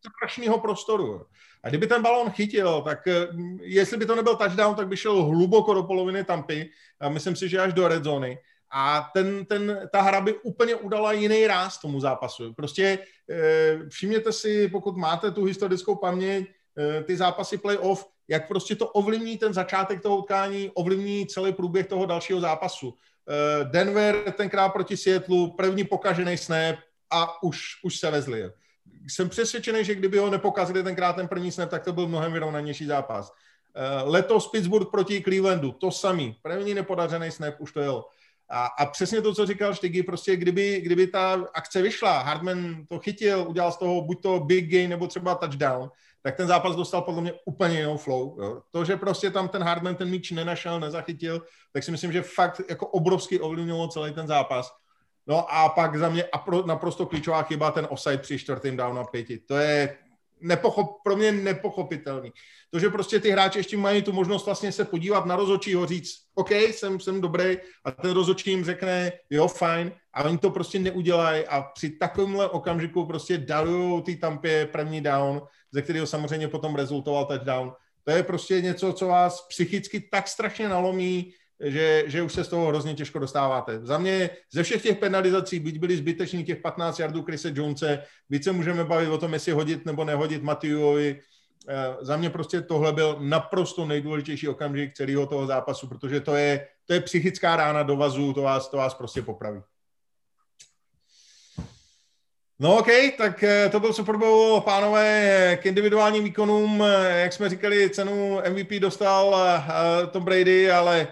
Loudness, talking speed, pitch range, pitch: -25 LUFS, 170 wpm, 155-195 Hz, 180 Hz